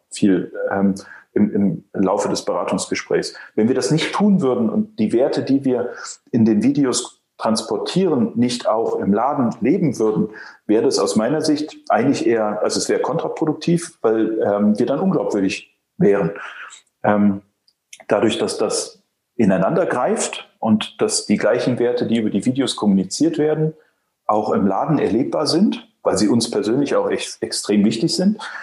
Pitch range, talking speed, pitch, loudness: 105-155 Hz, 160 wpm, 120 Hz, -19 LUFS